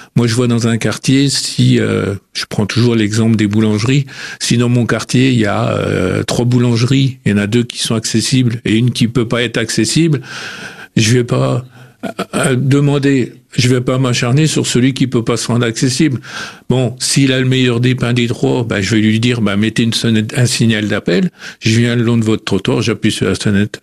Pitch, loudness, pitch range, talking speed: 120 Hz, -13 LUFS, 110-130 Hz, 225 wpm